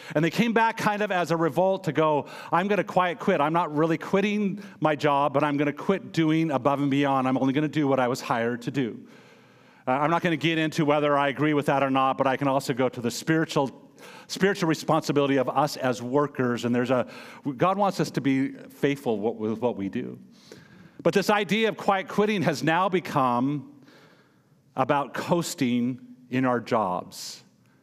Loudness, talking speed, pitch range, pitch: -25 LUFS, 210 wpm, 135-170 Hz, 150 Hz